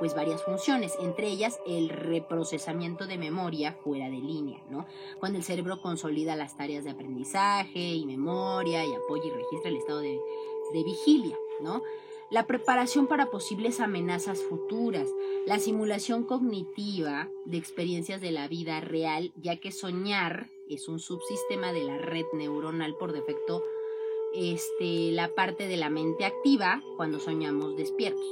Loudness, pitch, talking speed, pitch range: -31 LUFS, 185 Hz, 150 wpm, 160-225 Hz